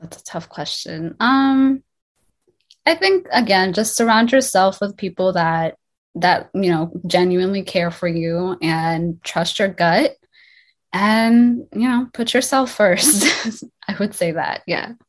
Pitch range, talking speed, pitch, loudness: 175-245 Hz, 145 wpm, 195 Hz, -17 LUFS